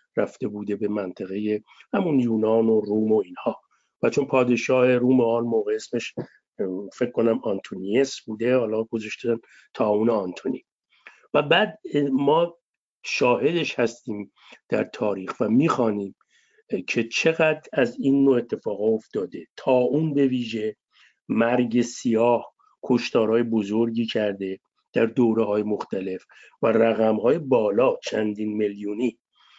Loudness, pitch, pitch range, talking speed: -23 LUFS, 115 Hz, 110-135 Hz, 125 wpm